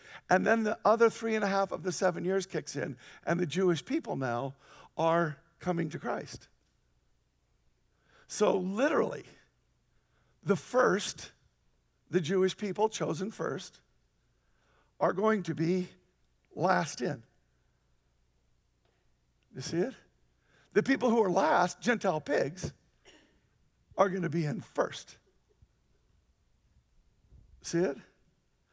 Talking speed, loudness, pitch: 115 wpm, -31 LUFS, 170 Hz